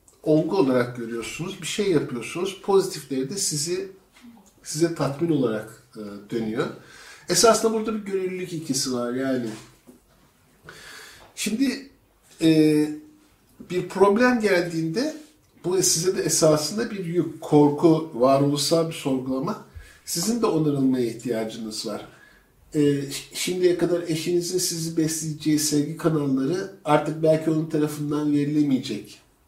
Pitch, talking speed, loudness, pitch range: 160 Hz, 110 wpm, -23 LUFS, 140-180 Hz